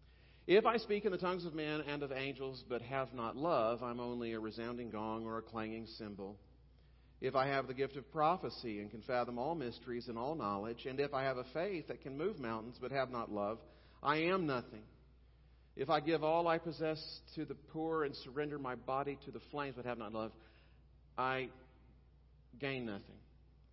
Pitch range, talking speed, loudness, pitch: 110-140 Hz, 200 wpm, -39 LUFS, 120 Hz